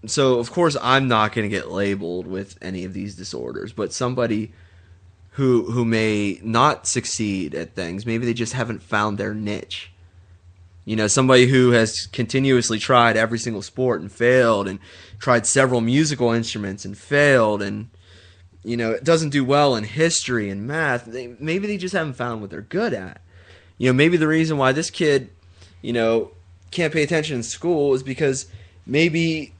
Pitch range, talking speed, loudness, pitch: 95-130 Hz, 175 wpm, -20 LUFS, 115 Hz